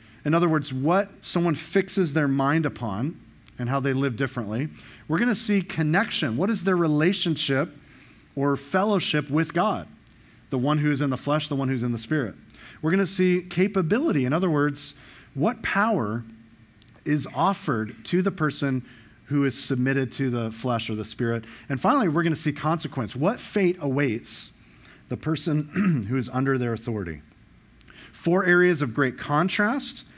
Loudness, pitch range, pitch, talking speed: -25 LUFS, 125-170 Hz, 145 Hz, 170 wpm